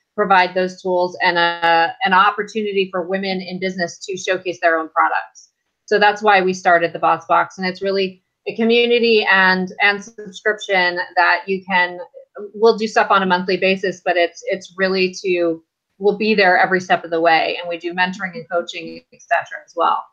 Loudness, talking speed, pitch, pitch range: -17 LUFS, 190 wpm, 185 Hz, 175-205 Hz